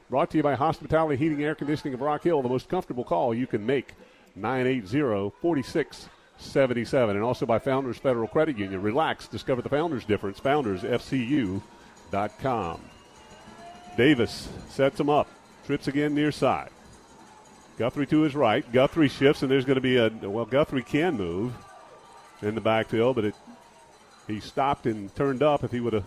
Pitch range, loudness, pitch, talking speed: 110-145 Hz, -26 LUFS, 130 Hz, 165 wpm